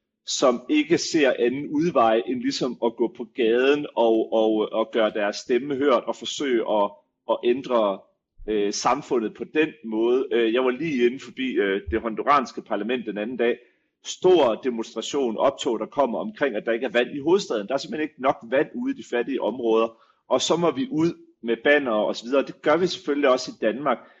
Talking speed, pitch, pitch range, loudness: 200 wpm, 125 Hz, 115-185 Hz, -23 LUFS